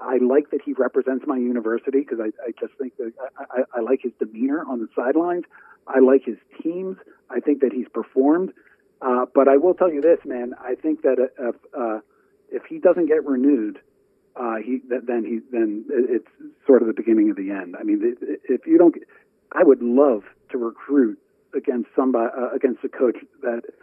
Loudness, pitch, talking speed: -21 LUFS, 180 Hz, 200 wpm